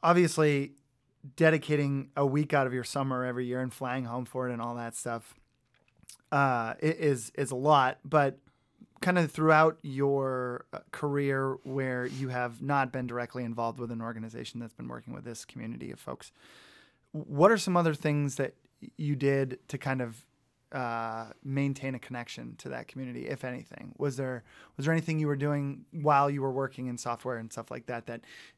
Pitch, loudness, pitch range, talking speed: 135 Hz, -30 LUFS, 125-145 Hz, 185 wpm